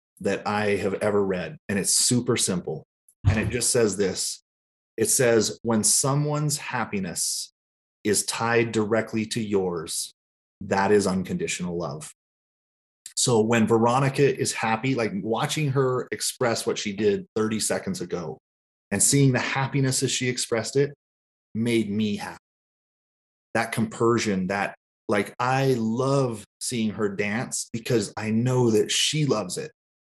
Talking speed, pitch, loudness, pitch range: 140 wpm, 115 Hz, -24 LUFS, 105-130 Hz